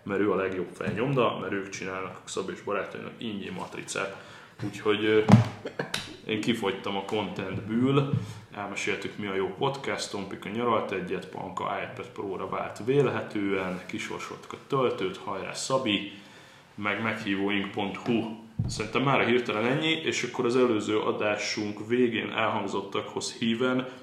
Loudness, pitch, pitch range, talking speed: -29 LUFS, 110 Hz, 100-120 Hz, 130 wpm